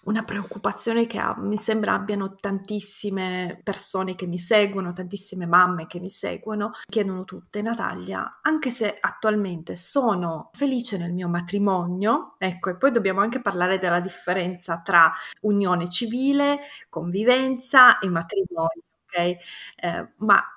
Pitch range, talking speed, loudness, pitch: 180-220 Hz, 130 wpm, -23 LUFS, 195 Hz